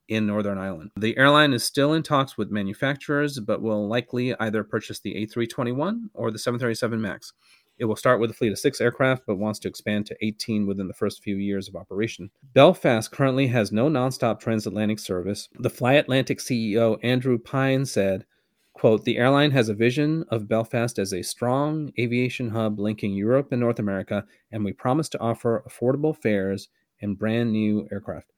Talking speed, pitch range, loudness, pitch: 185 wpm, 105-130 Hz, -24 LUFS, 115 Hz